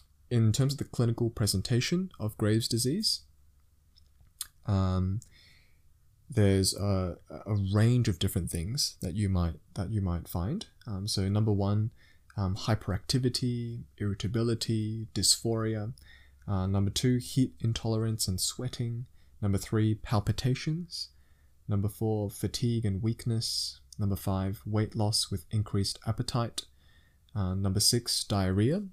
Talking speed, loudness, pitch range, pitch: 120 wpm, -30 LUFS, 95-115 Hz, 105 Hz